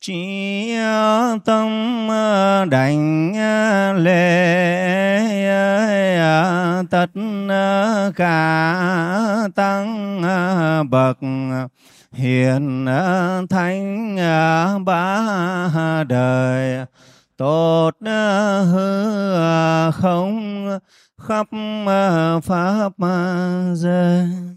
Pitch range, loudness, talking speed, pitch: 165-200 Hz, -18 LUFS, 45 wpm, 180 Hz